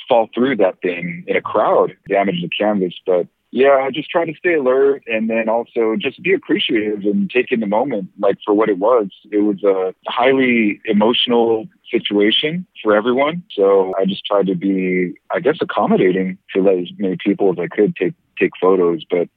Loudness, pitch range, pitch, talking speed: -17 LUFS, 95-125 Hz, 105 Hz, 195 wpm